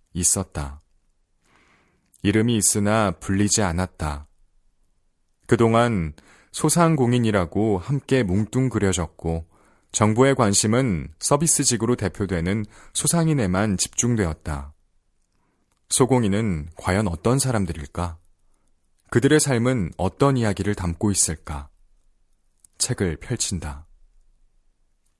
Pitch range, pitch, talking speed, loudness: 85-120 Hz, 100 Hz, 220 characters per minute, -21 LUFS